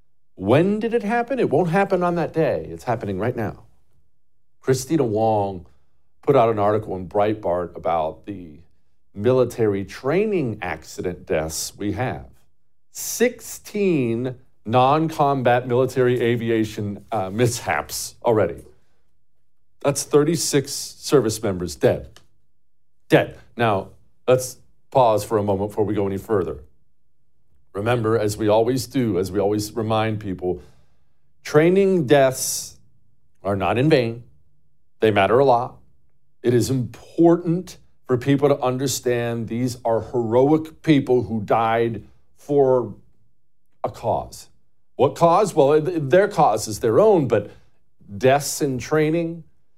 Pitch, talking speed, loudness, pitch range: 120 Hz, 125 wpm, -21 LUFS, 100-145 Hz